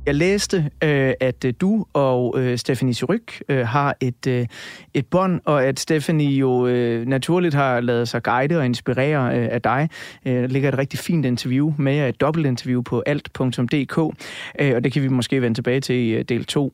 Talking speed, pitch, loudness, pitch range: 165 wpm, 135 Hz, -20 LUFS, 125-150 Hz